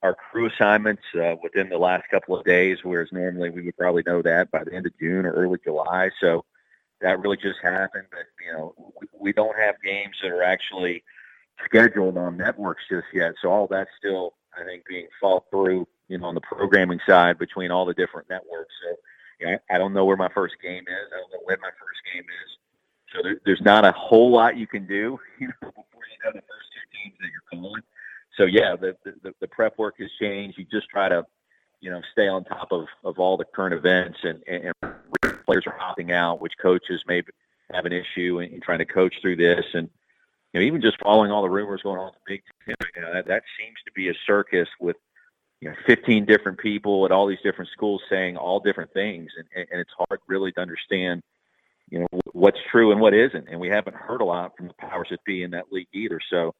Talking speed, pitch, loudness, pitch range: 230 wpm, 95 Hz, -22 LUFS, 90-100 Hz